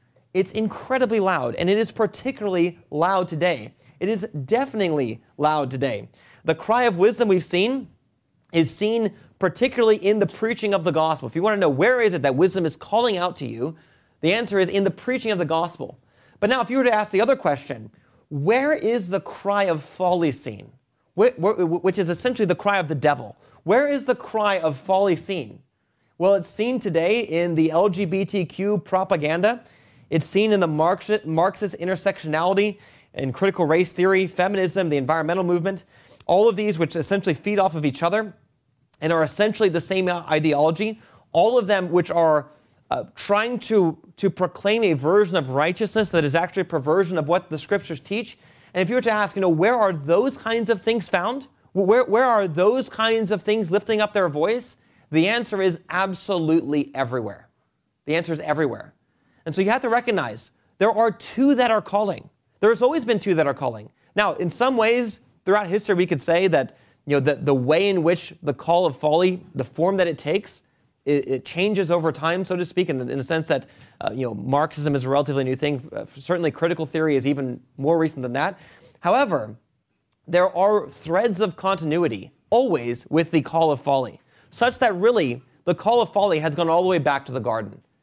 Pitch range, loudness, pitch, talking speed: 155-205 Hz, -22 LUFS, 180 Hz, 200 wpm